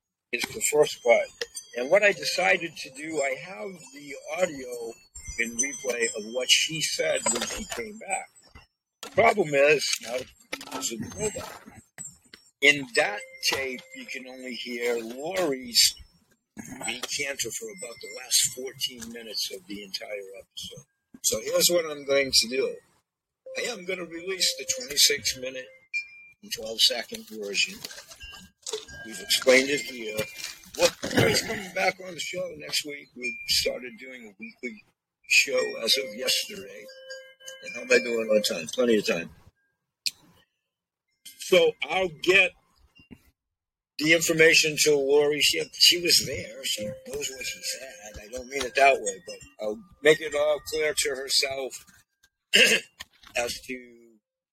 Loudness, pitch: -24 LUFS, 155 Hz